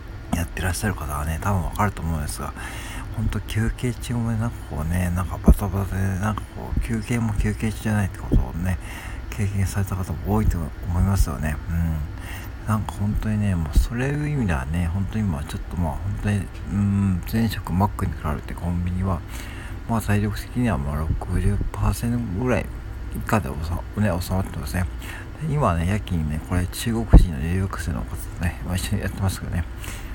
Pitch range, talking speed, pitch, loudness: 85-105 Hz, 370 characters per minute, 95 Hz, -25 LUFS